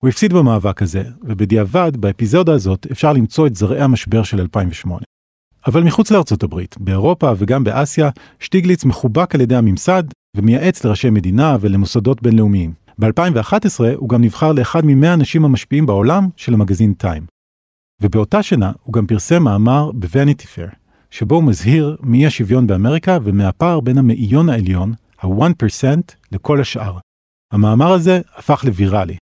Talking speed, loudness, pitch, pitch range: 140 wpm, -14 LUFS, 120 Hz, 105-150 Hz